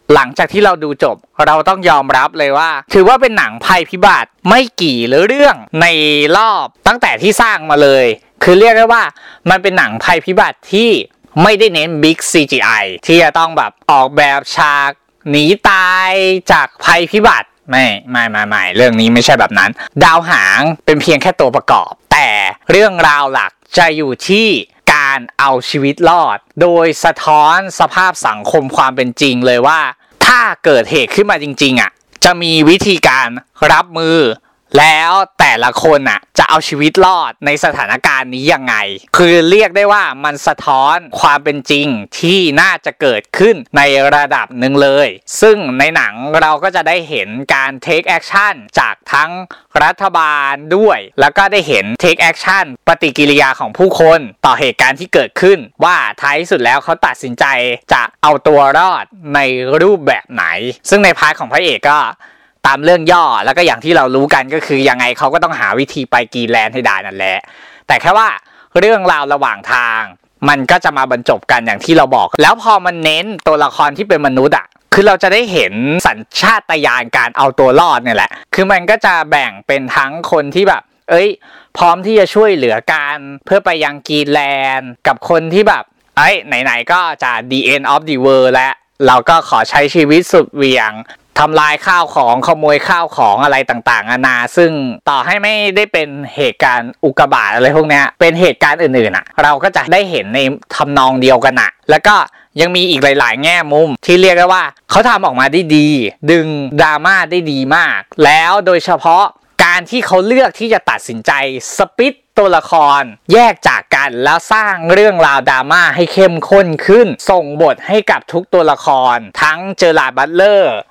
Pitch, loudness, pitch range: 155 Hz, -10 LUFS, 140-185 Hz